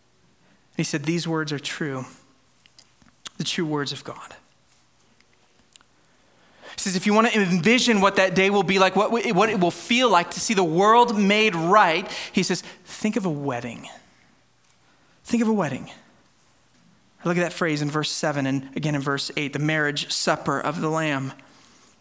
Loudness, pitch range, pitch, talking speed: -22 LUFS, 145-200 Hz, 170 Hz, 175 wpm